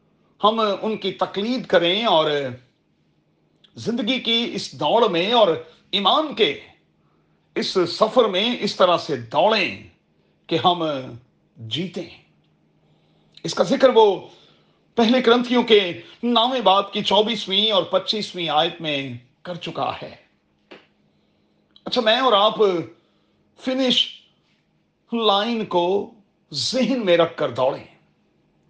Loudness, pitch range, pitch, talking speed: -20 LUFS, 170-230 Hz, 200 Hz, 115 wpm